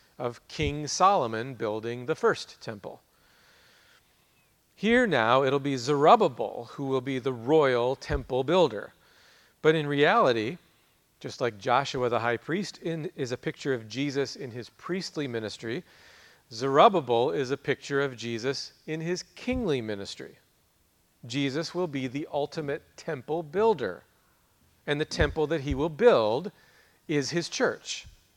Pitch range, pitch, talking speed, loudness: 125-160 Hz, 140 Hz, 140 wpm, -27 LUFS